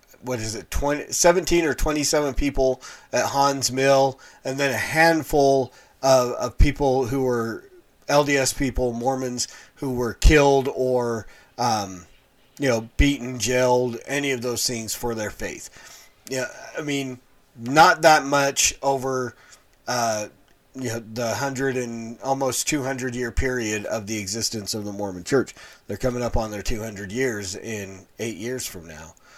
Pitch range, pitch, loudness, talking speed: 115-140 Hz, 130 Hz, -23 LUFS, 150 wpm